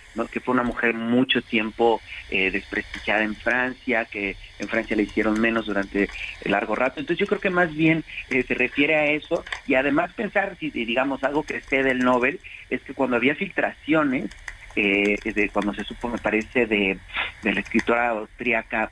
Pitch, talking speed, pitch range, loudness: 120 Hz, 185 wpm, 105-135 Hz, -23 LUFS